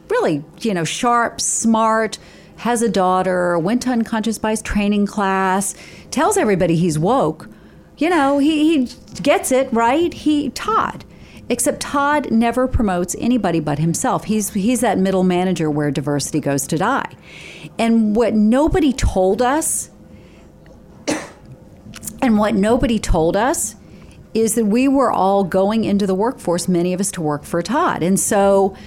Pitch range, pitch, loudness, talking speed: 180-250 Hz, 215 Hz, -17 LUFS, 150 wpm